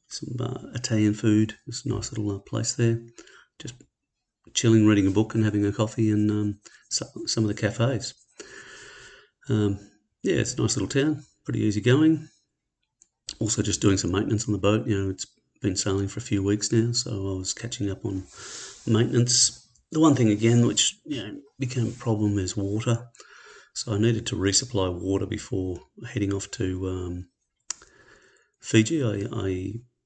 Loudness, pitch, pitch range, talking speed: -25 LUFS, 110 Hz, 100-120 Hz, 175 wpm